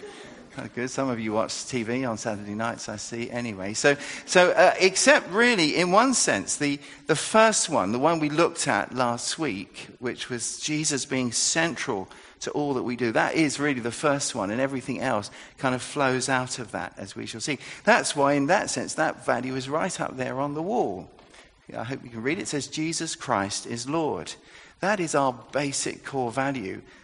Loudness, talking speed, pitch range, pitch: -25 LUFS, 205 wpm, 120-155 Hz, 135 Hz